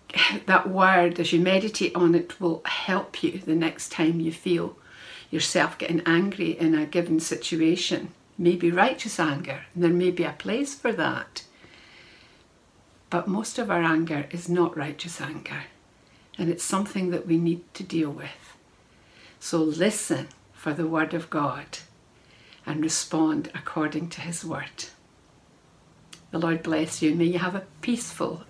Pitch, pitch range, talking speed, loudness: 170 Hz, 160-180 Hz, 155 wpm, -25 LUFS